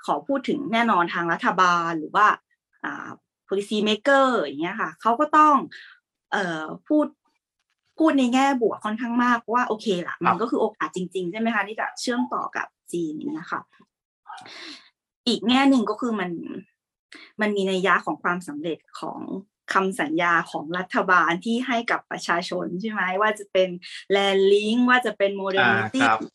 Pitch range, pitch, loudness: 185-250 Hz, 210 Hz, -23 LUFS